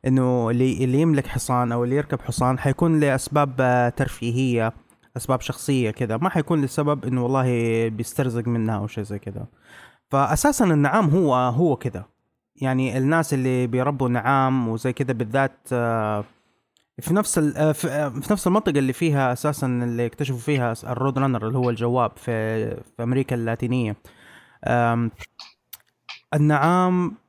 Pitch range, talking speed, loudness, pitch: 120-145 Hz, 130 wpm, -22 LUFS, 130 Hz